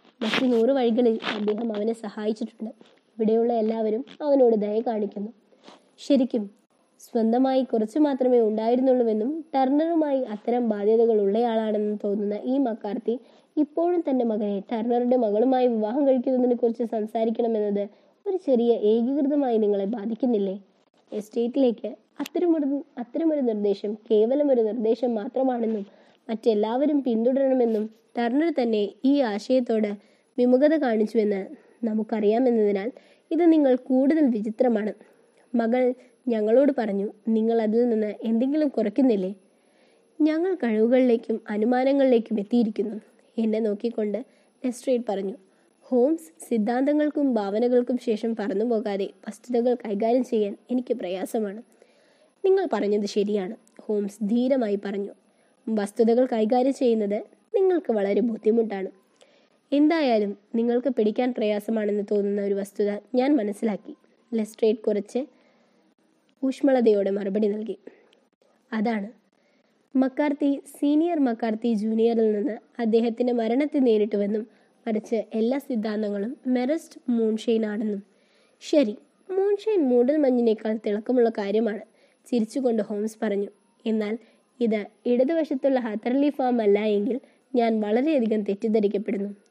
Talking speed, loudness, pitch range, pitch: 95 wpm, -24 LUFS, 215-260 Hz, 230 Hz